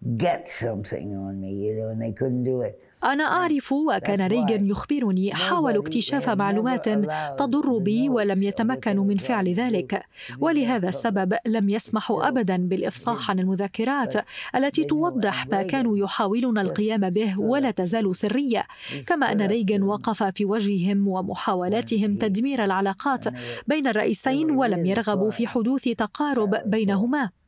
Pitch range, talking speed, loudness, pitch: 195-245 Hz, 110 wpm, -24 LUFS, 215 Hz